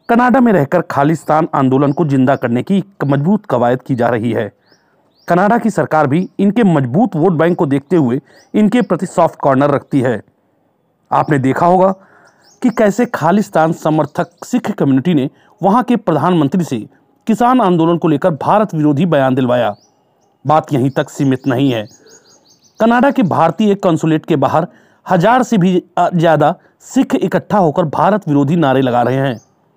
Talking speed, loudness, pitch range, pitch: 160 wpm, -13 LUFS, 140-190 Hz, 165 Hz